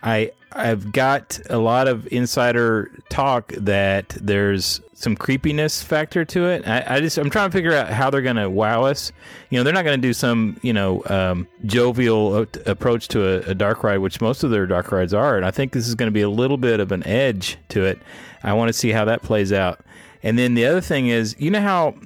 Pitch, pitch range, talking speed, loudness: 115 Hz, 100-135 Hz, 235 wpm, -20 LUFS